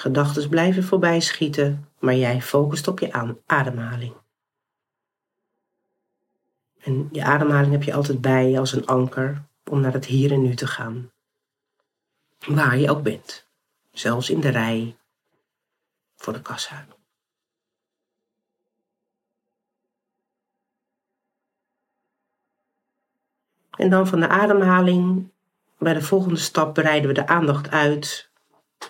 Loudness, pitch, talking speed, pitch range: -21 LUFS, 150 Hz, 110 wpm, 130-185 Hz